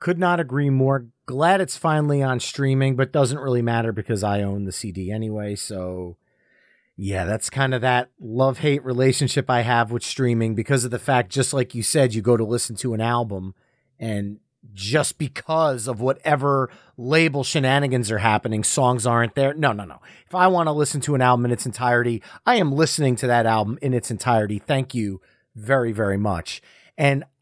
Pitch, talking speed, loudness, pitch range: 125 Hz, 195 wpm, -21 LUFS, 110-140 Hz